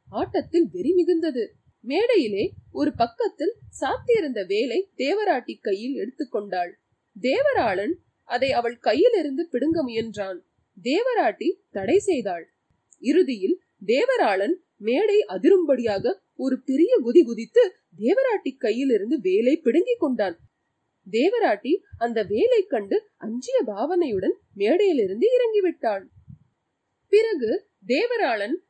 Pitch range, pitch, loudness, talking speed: 255-405 Hz, 345 Hz, -23 LUFS, 95 wpm